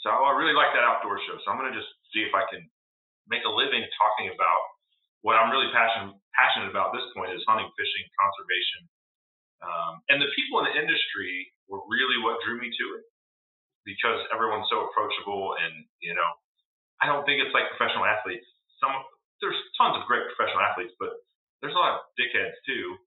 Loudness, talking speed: -26 LUFS, 200 wpm